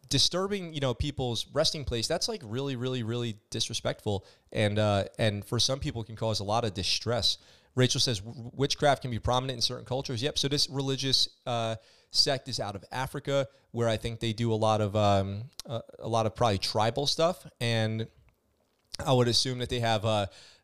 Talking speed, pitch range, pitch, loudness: 200 wpm, 110-135 Hz, 120 Hz, -29 LUFS